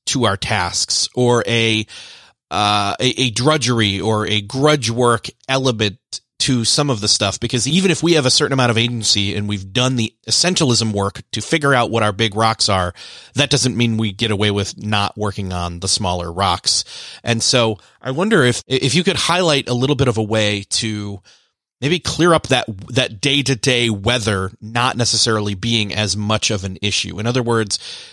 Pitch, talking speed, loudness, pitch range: 115 Hz, 195 wpm, -17 LUFS, 105-130 Hz